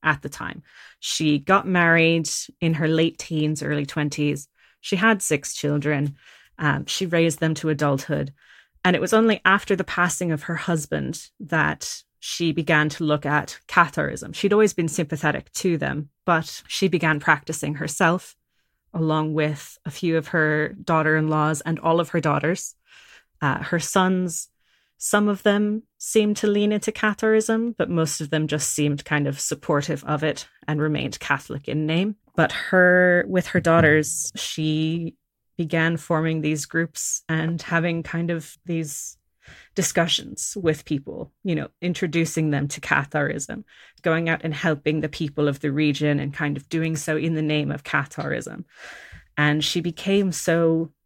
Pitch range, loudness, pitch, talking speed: 150-175 Hz, -22 LUFS, 160 Hz, 160 wpm